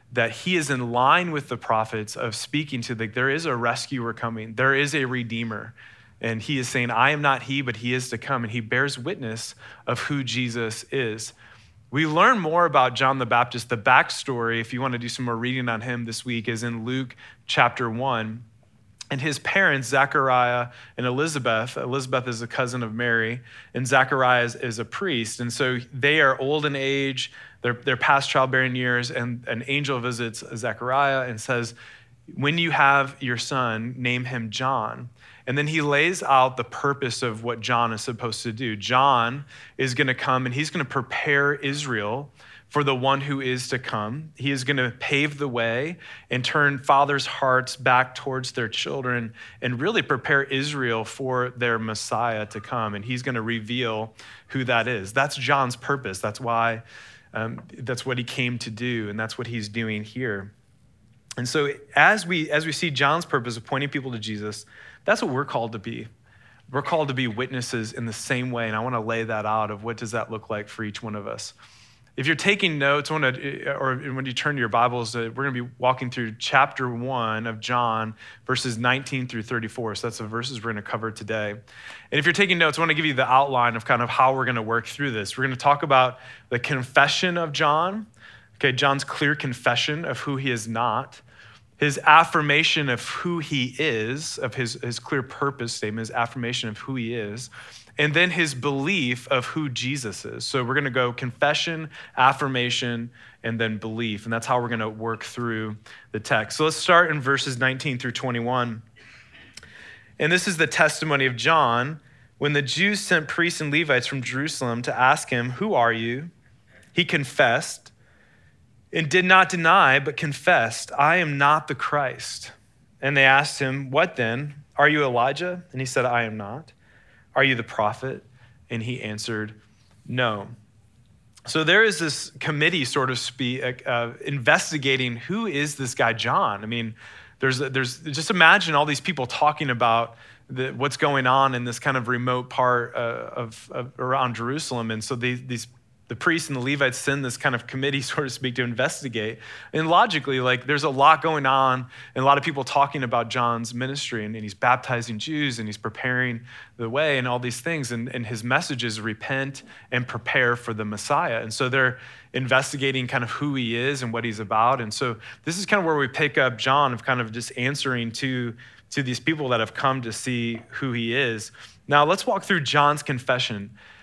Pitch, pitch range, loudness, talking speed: 125 Hz, 115-140 Hz, -23 LUFS, 195 wpm